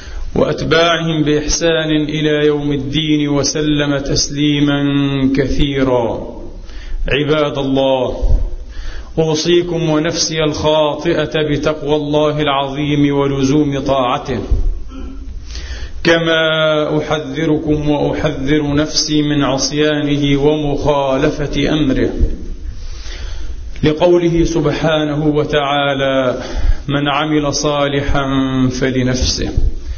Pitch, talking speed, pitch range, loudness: 145 Hz, 65 wpm, 135-150 Hz, -15 LUFS